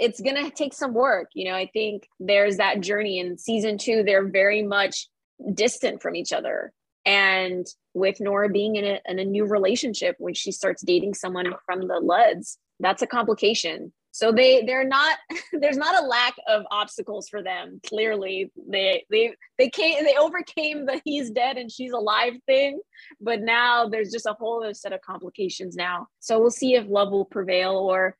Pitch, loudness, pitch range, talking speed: 210 Hz, -23 LUFS, 195-255 Hz, 185 wpm